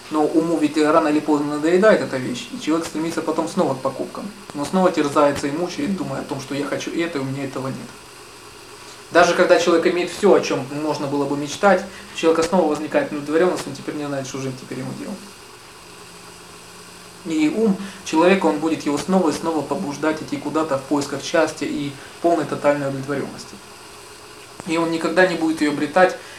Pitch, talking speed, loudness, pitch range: 150 Hz, 190 wpm, -20 LUFS, 145-170 Hz